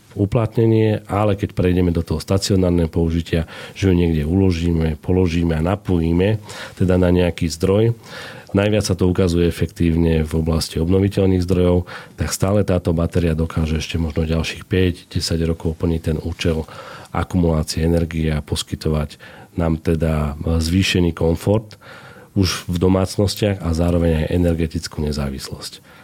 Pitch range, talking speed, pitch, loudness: 80-95 Hz, 130 wpm, 85 Hz, -19 LUFS